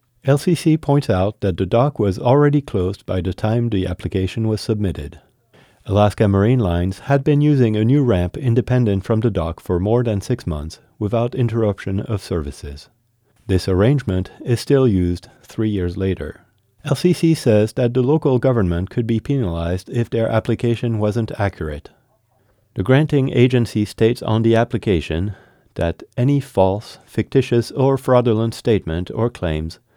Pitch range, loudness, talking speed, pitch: 95-125 Hz, -18 LUFS, 150 wpm, 115 Hz